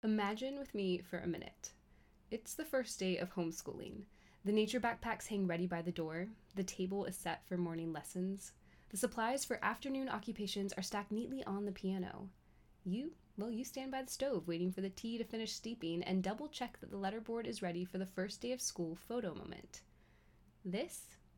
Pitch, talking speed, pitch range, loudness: 200 Hz, 195 wpm, 180-230 Hz, -42 LUFS